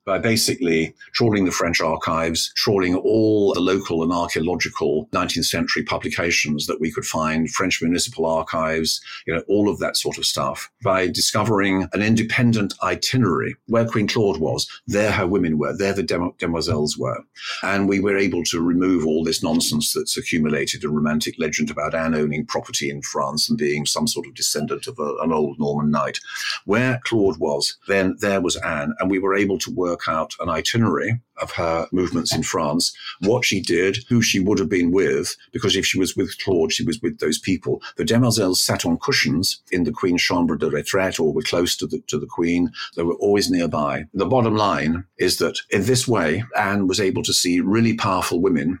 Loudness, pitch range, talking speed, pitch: -20 LUFS, 80-110 Hz, 195 wpm, 95 Hz